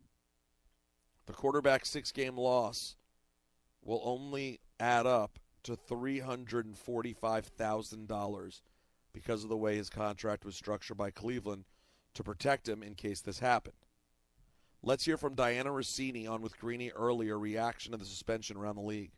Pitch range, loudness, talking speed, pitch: 100-120 Hz, -36 LUFS, 140 wpm, 110 Hz